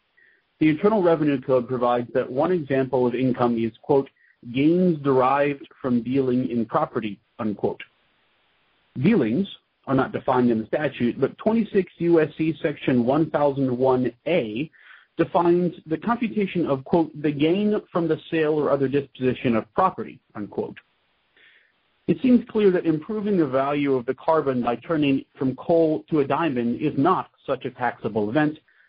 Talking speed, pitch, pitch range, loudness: 145 wpm, 145 Hz, 130-165 Hz, -23 LUFS